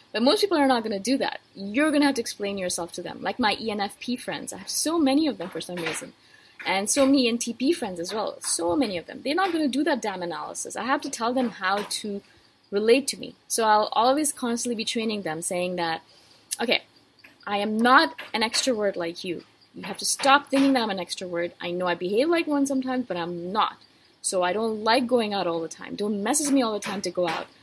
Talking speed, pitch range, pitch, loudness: 250 wpm, 190-270 Hz, 225 Hz, -25 LUFS